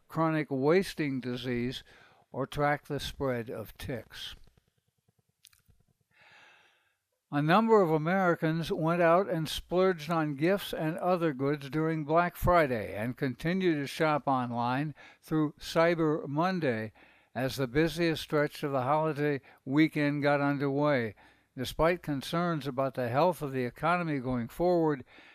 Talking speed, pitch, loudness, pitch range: 125 wpm, 150 Hz, -30 LUFS, 135-165 Hz